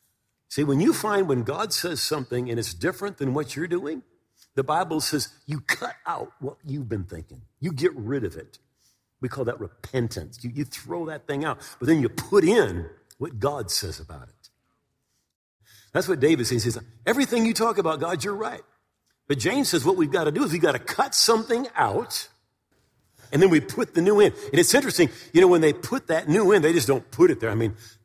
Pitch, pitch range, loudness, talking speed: 150 Hz, 125-195 Hz, -23 LUFS, 220 wpm